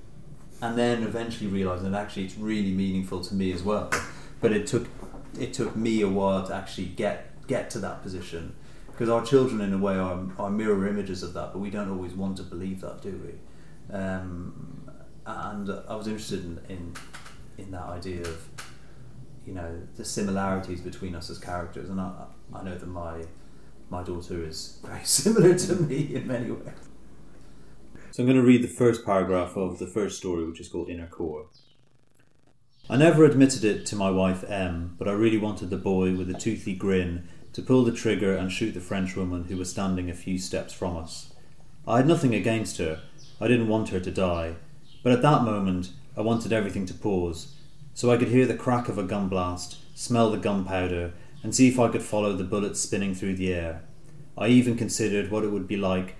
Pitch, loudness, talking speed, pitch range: 100 Hz, -26 LUFS, 200 wpm, 90-120 Hz